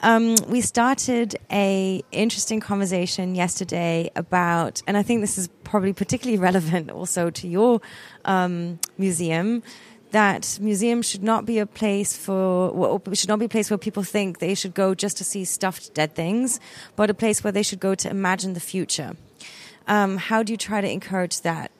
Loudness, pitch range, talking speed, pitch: -23 LUFS, 185-215 Hz, 180 wpm, 195 Hz